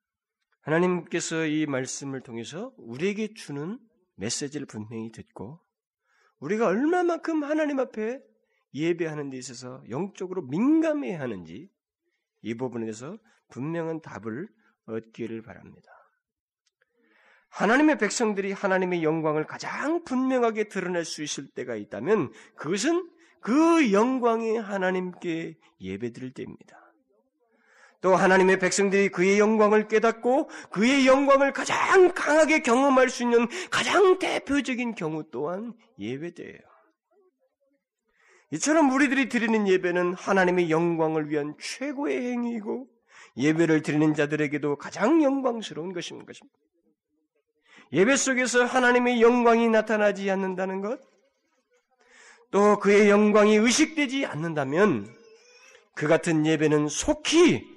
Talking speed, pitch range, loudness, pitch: 280 characters per minute, 155-260 Hz, -24 LUFS, 205 Hz